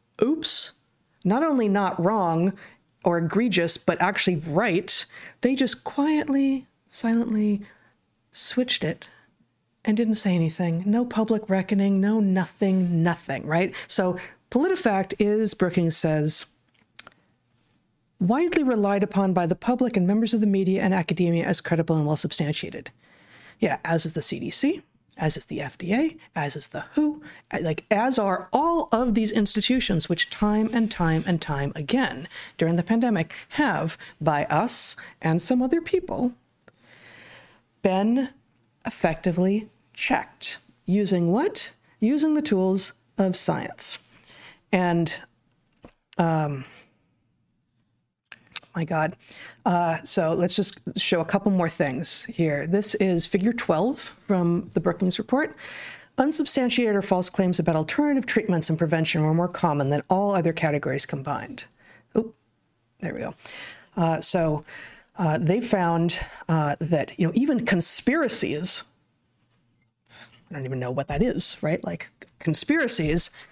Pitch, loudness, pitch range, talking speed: 190 Hz, -23 LUFS, 165-225 Hz, 130 wpm